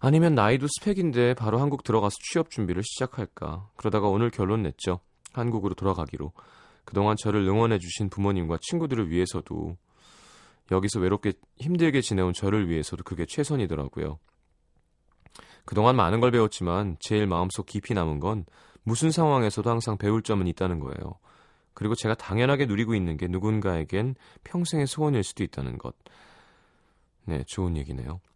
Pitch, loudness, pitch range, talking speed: 100 Hz, -27 LUFS, 90-120 Hz, 365 characters per minute